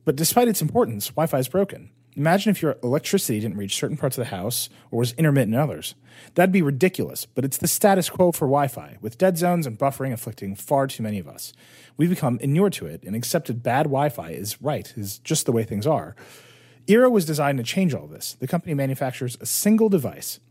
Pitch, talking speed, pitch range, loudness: 140 Hz, 225 wpm, 120-170 Hz, -23 LUFS